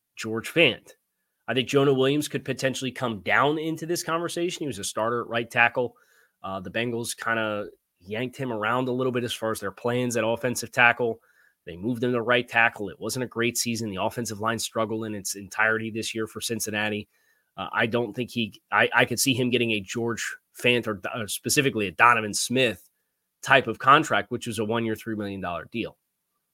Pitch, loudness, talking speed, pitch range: 115 Hz, -25 LUFS, 210 wpm, 110-125 Hz